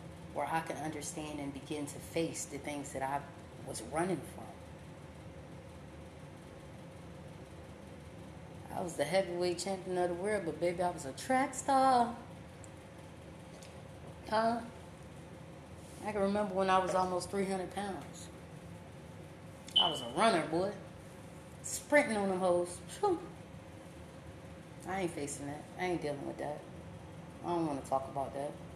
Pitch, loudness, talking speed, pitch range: 175 Hz, -35 LUFS, 135 wpm, 145-195 Hz